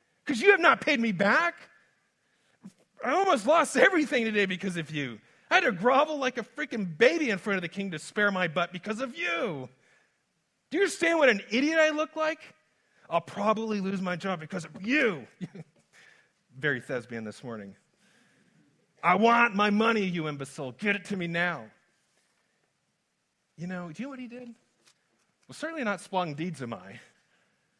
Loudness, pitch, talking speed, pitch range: -27 LUFS, 205 Hz, 175 wpm, 170-255 Hz